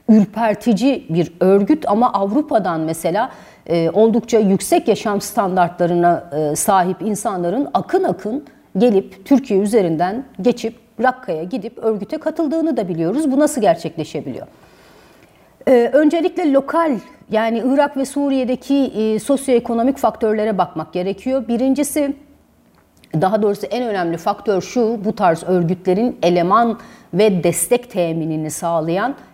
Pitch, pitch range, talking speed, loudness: 220 Hz, 180-260 Hz, 115 wpm, -17 LUFS